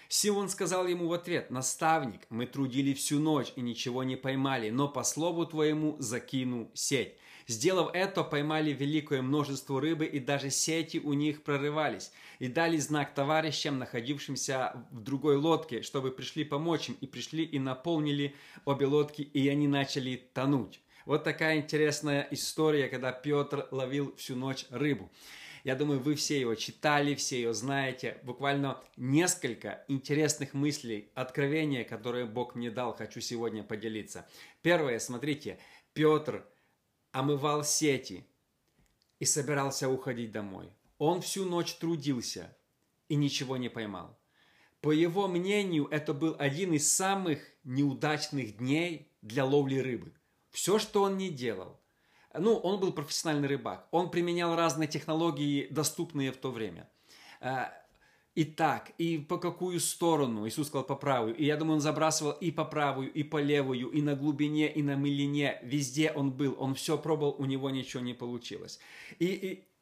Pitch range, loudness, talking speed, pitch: 130-155 Hz, -32 LUFS, 150 wpm, 145 Hz